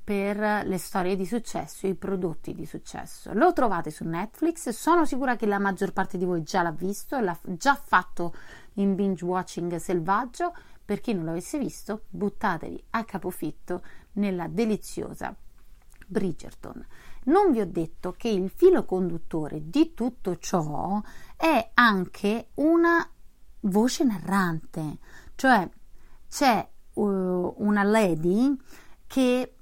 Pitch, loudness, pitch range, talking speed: 200 Hz, -26 LUFS, 180-240 Hz, 130 wpm